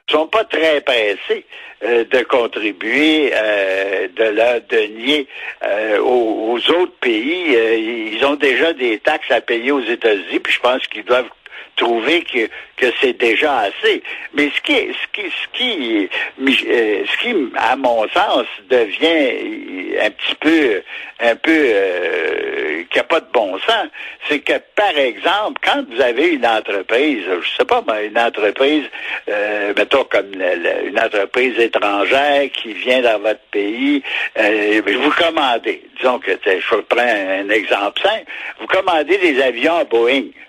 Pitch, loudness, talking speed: 360 Hz, -16 LUFS, 155 wpm